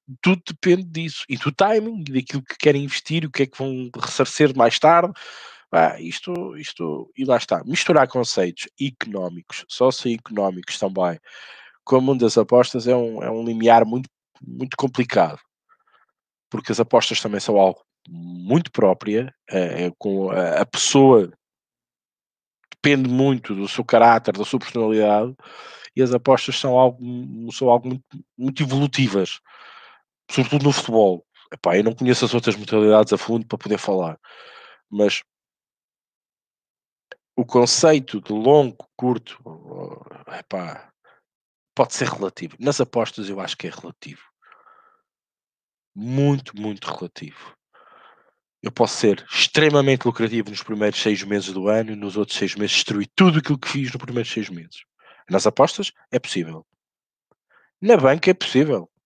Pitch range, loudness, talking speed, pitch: 105-140 Hz, -20 LUFS, 145 wpm, 125 Hz